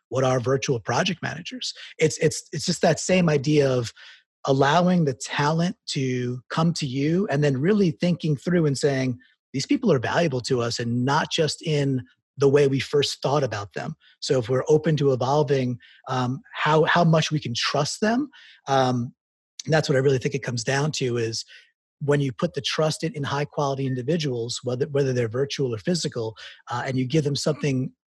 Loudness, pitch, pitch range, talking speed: -23 LUFS, 140 Hz, 130-160 Hz, 190 wpm